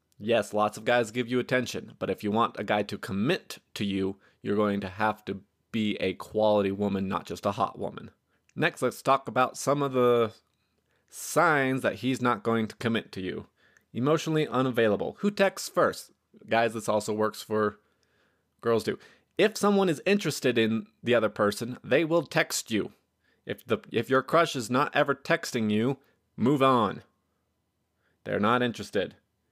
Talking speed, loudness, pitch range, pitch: 175 wpm, -27 LUFS, 105-130 Hz, 115 Hz